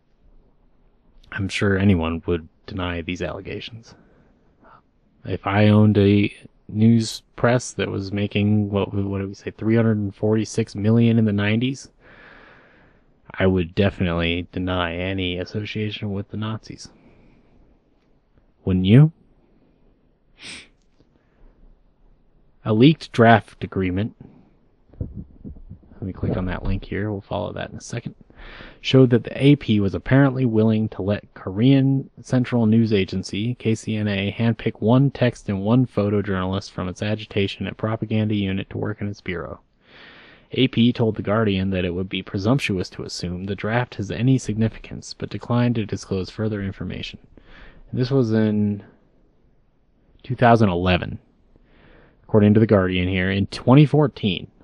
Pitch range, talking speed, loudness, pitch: 95-115 Hz, 135 wpm, -21 LUFS, 105 Hz